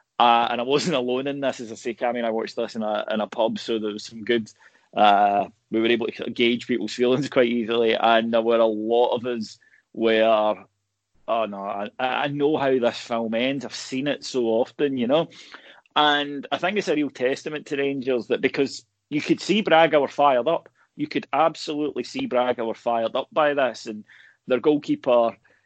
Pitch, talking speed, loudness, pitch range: 120 Hz, 210 wpm, -23 LUFS, 115-140 Hz